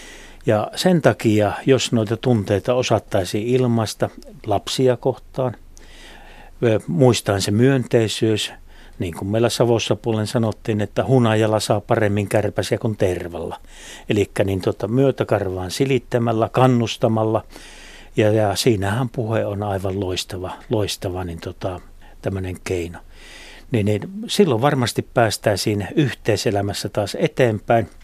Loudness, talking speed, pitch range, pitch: -20 LUFS, 110 wpm, 100-125 Hz, 110 Hz